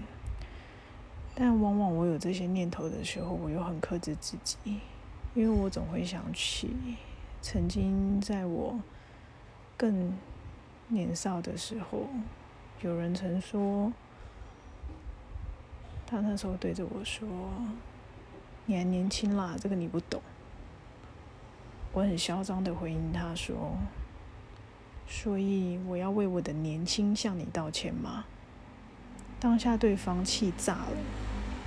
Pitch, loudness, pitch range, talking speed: 180 Hz, -33 LUFS, 120-200 Hz, 165 characters per minute